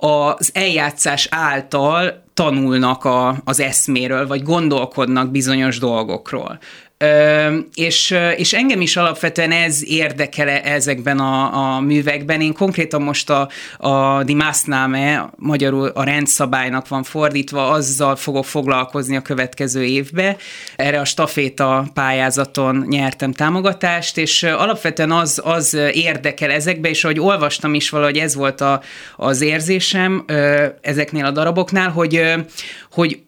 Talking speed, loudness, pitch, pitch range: 120 wpm, -16 LUFS, 145 Hz, 135-160 Hz